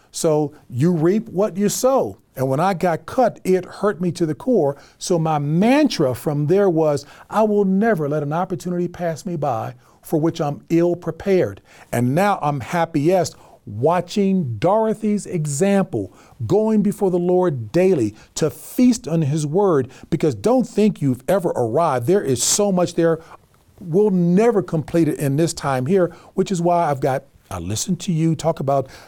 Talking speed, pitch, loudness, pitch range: 175 wpm, 170 Hz, -19 LUFS, 150-195 Hz